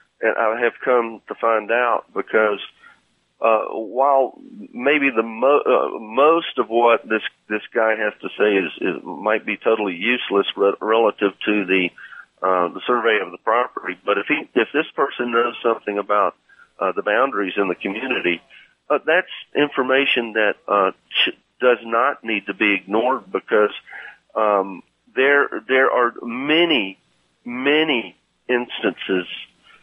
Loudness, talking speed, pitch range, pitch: -20 LUFS, 150 wpm, 100-125 Hz, 115 Hz